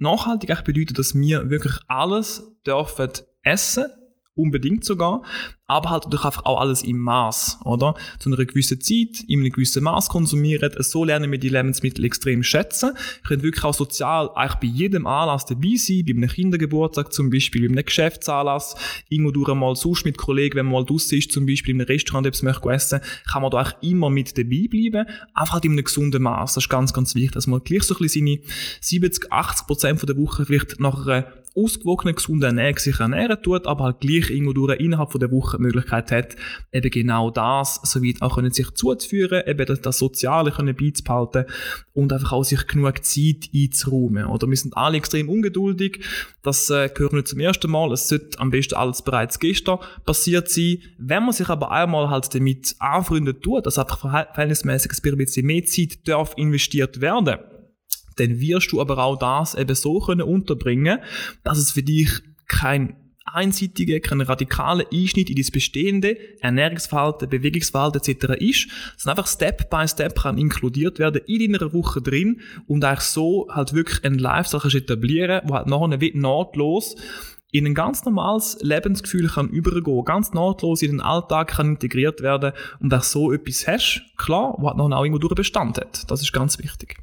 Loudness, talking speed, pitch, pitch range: -21 LUFS, 185 wpm, 145 Hz, 135-170 Hz